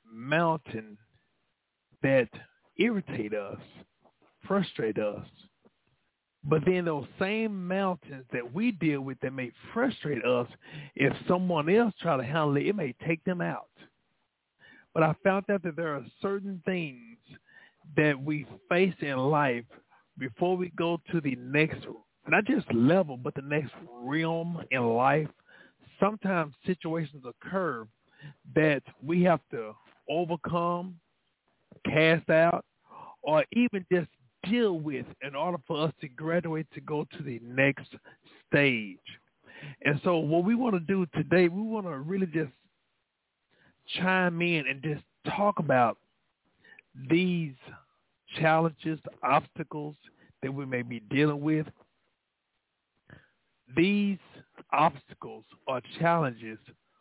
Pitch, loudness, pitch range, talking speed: 160 Hz, -29 LUFS, 135-180 Hz, 125 wpm